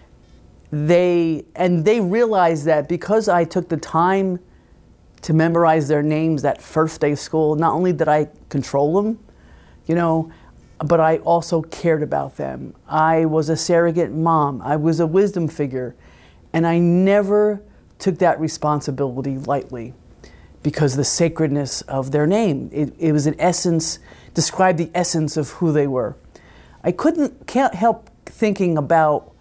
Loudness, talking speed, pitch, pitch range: -19 LUFS, 155 wpm, 160 Hz, 150-175 Hz